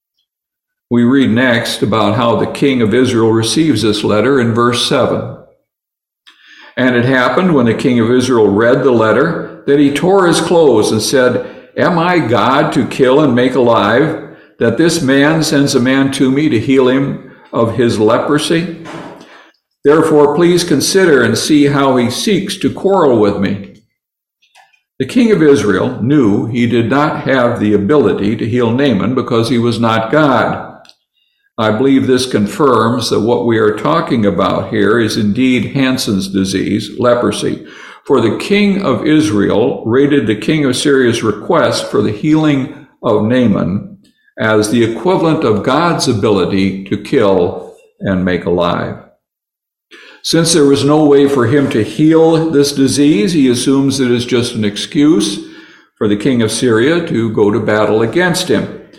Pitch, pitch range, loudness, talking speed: 130 Hz, 115-150 Hz, -12 LUFS, 160 wpm